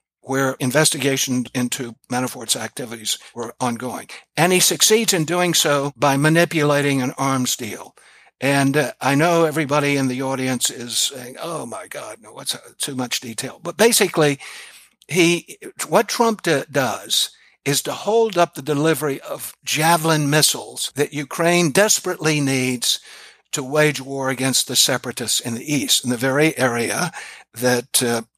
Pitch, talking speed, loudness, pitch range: 145 Hz, 150 wpm, -19 LUFS, 130-160 Hz